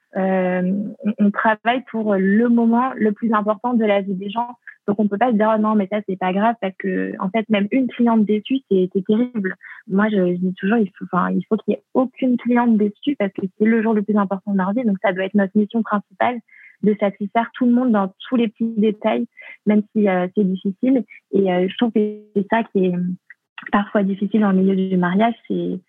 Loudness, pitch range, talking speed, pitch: -19 LUFS, 195-230 Hz, 240 wpm, 210 Hz